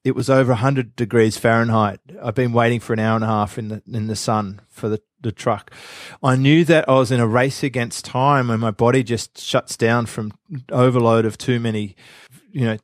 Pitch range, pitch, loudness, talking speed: 110-130 Hz, 120 Hz, -19 LUFS, 220 wpm